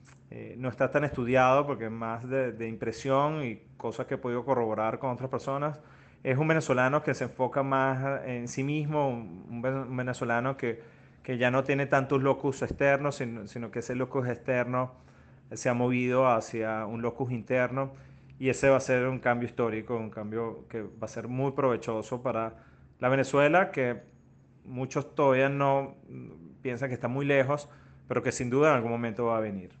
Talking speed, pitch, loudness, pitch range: 185 wpm, 130 Hz, -29 LUFS, 115-135 Hz